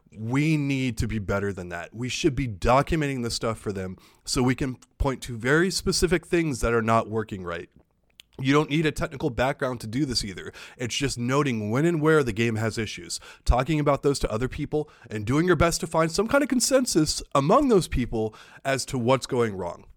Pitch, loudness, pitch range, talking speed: 130 Hz, -25 LUFS, 115-155 Hz, 215 wpm